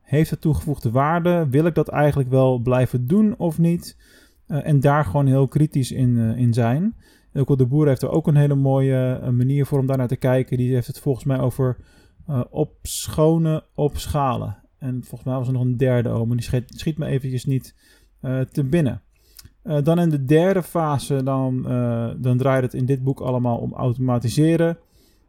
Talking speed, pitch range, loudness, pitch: 205 wpm, 125-150 Hz, -21 LUFS, 135 Hz